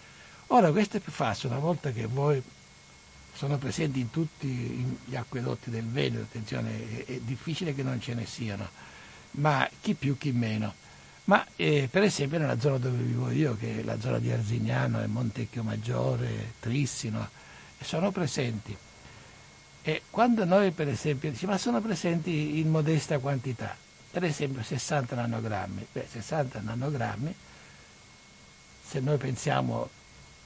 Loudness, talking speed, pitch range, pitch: -30 LUFS, 140 wpm, 115-150 Hz, 130 Hz